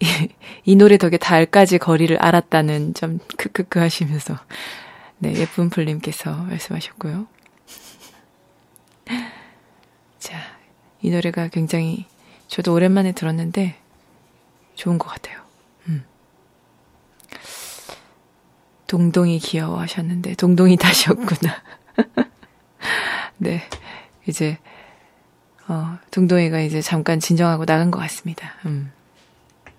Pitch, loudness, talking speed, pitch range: 170 Hz, -19 LUFS, 210 characters per minute, 160-180 Hz